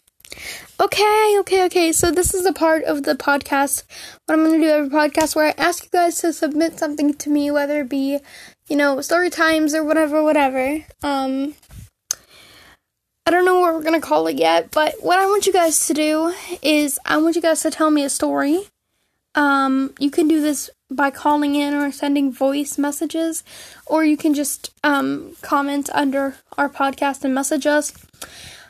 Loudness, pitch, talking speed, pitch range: -18 LUFS, 300 Hz, 190 wpm, 285-325 Hz